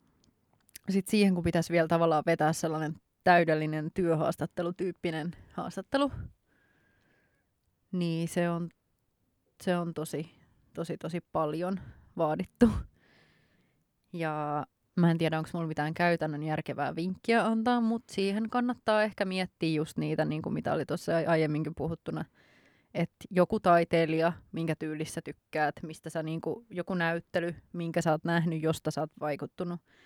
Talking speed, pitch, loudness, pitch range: 130 wpm, 170 Hz, -31 LUFS, 155-180 Hz